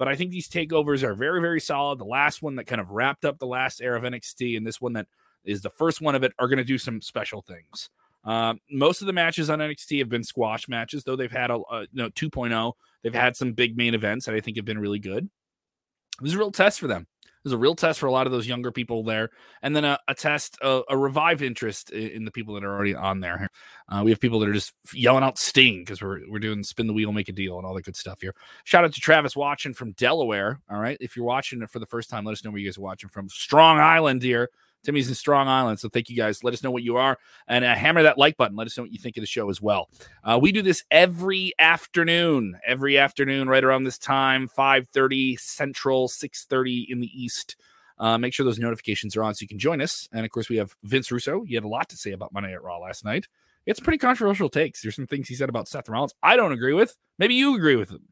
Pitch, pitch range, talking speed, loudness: 125 Hz, 115-145 Hz, 270 wpm, -23 LUFS